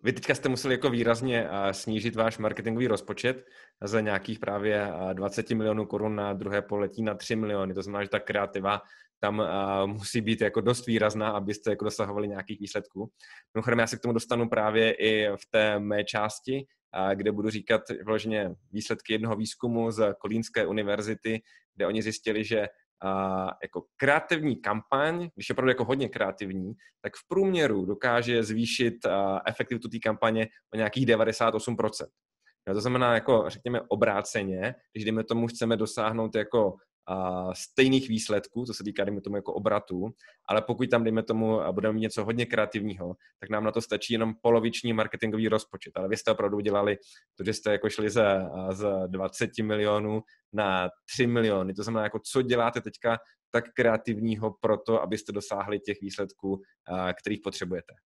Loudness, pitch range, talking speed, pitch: -28 LUFS, 100-115 Hz, 165 wpm, 110 Hz